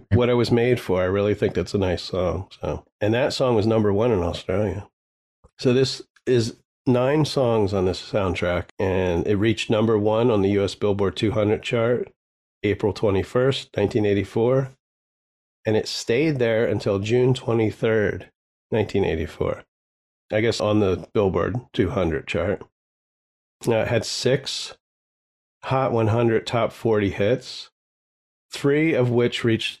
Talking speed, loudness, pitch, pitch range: 145 wpm, -22 LUFS, 110 Hz, 100-125 Hz